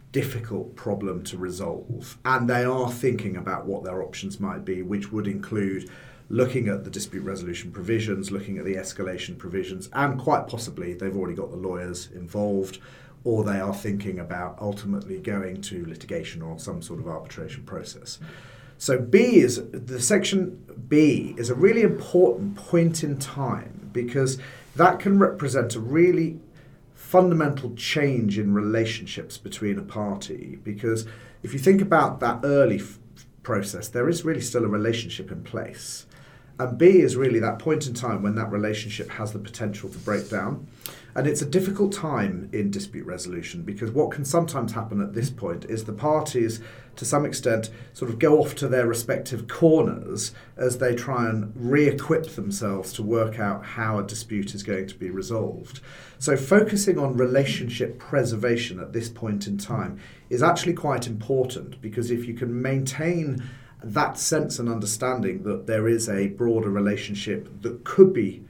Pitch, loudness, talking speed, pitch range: 120 Hz, -25 LUFS, 170 wpm, 105-140 Hz